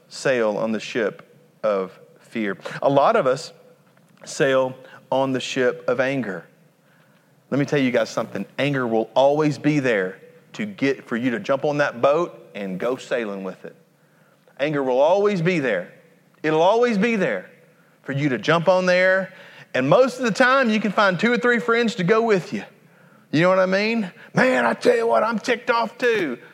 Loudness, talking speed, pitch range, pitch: -21 LUFS, 195 wpm, 140-210 Hz, 170 Hz